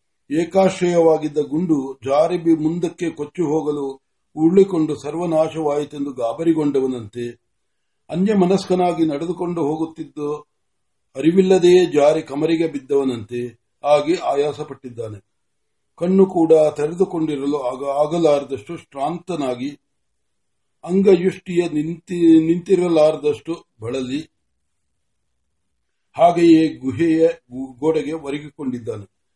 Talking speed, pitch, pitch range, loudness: 60 wpm, 155 Hz, 135-170 Hz, -19 LUFS